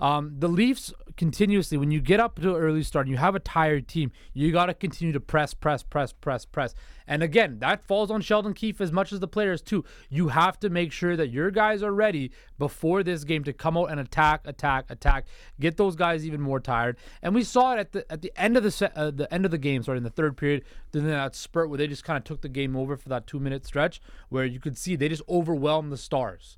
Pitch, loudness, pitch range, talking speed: 160 Hz, -26 LUFS, 145-185 Hz, 260 wpm